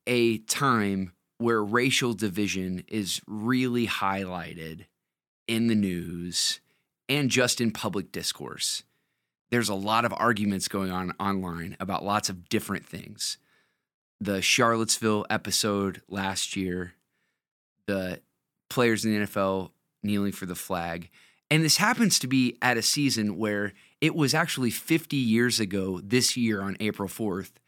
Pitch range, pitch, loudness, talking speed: 95-120 Hz, 105 Hz, -27 LUFS, 135 wpm